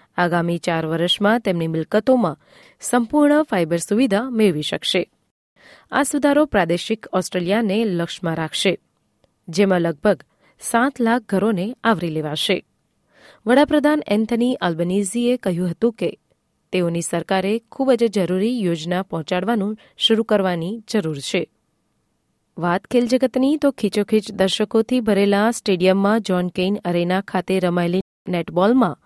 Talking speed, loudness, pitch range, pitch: 110 wpm, -20 LUFS, 175-230 Hz, 200 Hz